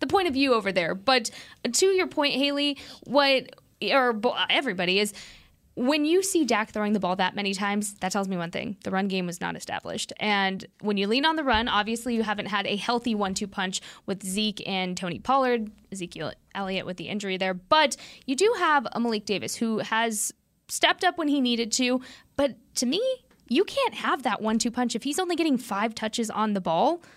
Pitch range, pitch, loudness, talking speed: 200-275 Hz, 230 Hz, -26 LUFS, 210 wpm